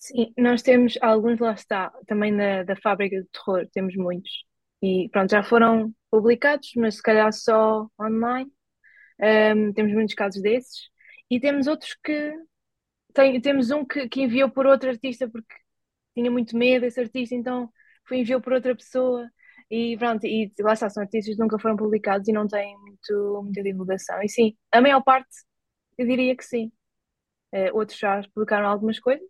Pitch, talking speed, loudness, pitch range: 230 Hz, 175 wpm, -23 LUFS, 210-255 Hz